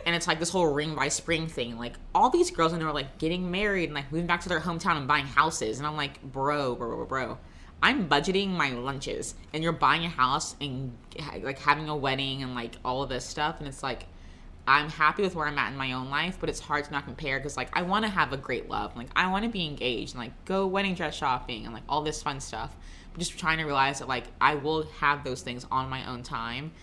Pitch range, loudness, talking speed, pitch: 130-165 Hz, -28 LUFS, 255 wpm, 145 Hz